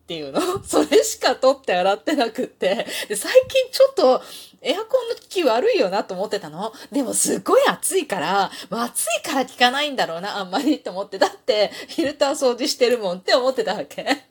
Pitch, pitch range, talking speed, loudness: 275 Hz, 220-370 Hz, 405 characters per minute, -20 LUFS